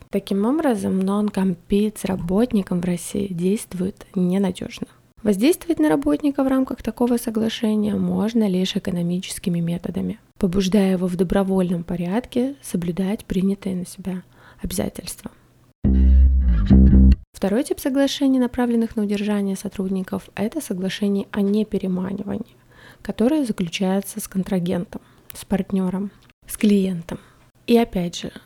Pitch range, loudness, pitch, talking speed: 185-225 Hz, -21 LUFS, 200 Hz, 110 wpm